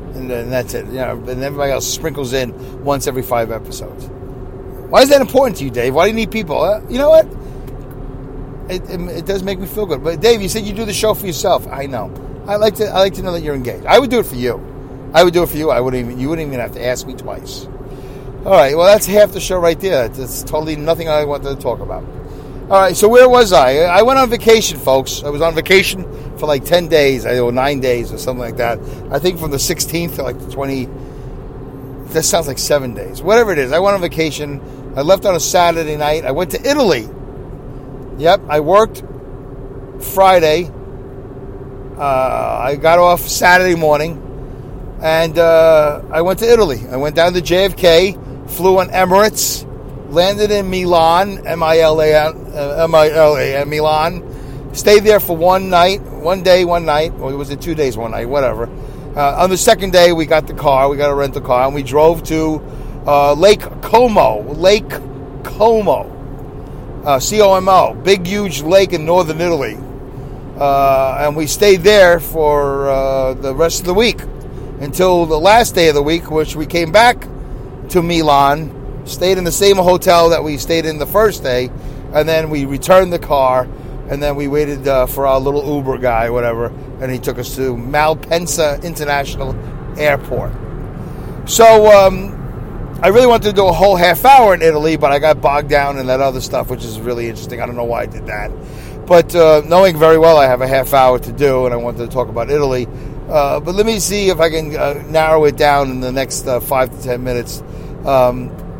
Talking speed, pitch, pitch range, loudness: 205 wpm, 145 Hz, 130-175 Hz, -13 LUFS